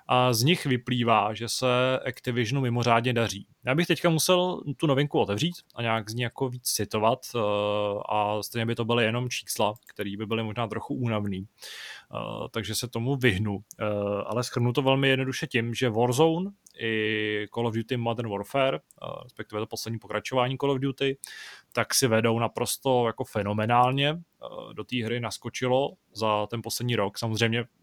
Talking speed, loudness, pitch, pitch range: 165 wpm, -27 LUFS, 120 Hz, 110-130 Hz